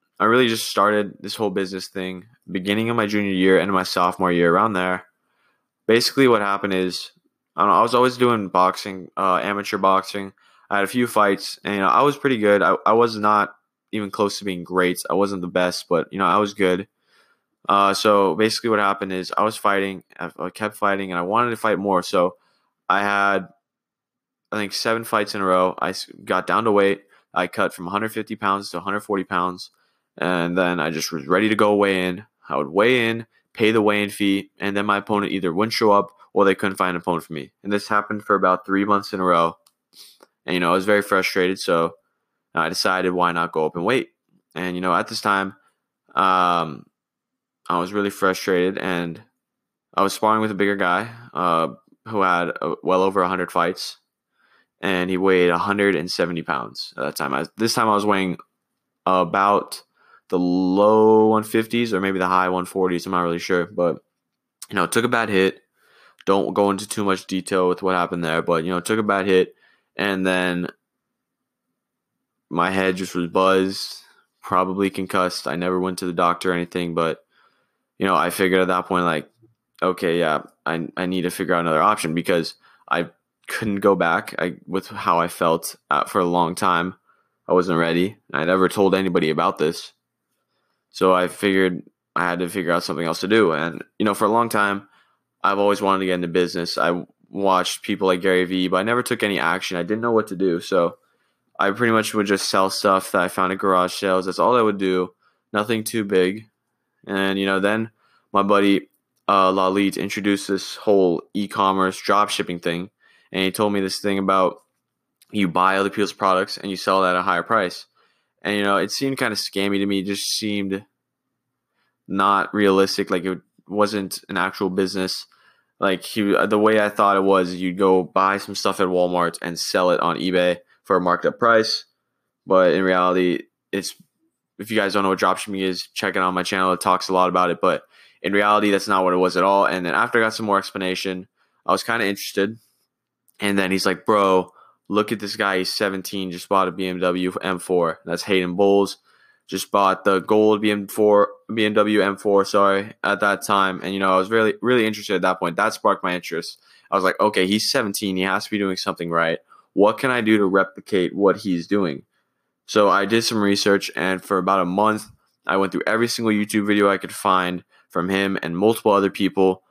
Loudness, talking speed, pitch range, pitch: -20 LUFS, 210 wpm, 90-105 Hz, 95 Hz